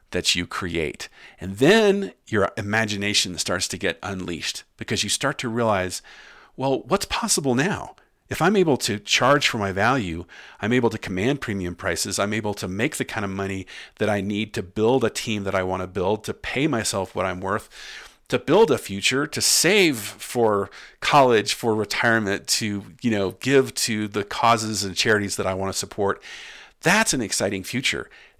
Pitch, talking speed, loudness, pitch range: 105 Hz, 185 wpm, -22 LUFS, 95-115 Hz